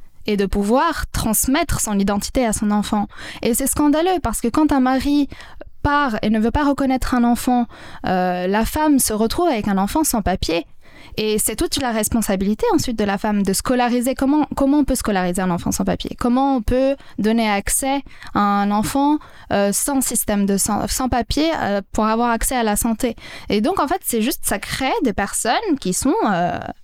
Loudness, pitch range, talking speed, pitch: -19 LUFS, 210-275 Hz, 200 wpm, 235 Hz